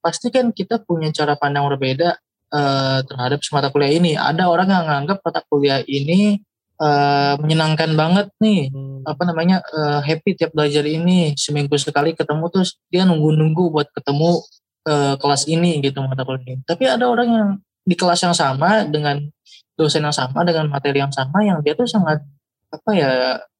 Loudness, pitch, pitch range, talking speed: -18 LUFS, 155 Hz, 140-175 Hz, 175 wpm